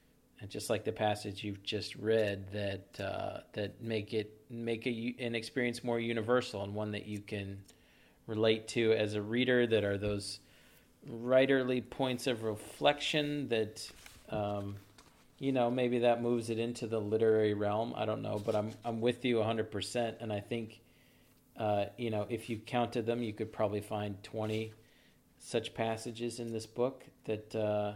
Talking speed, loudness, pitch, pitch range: 170 wpm, -35 LUFS, 110 Hz, 105-120 Hz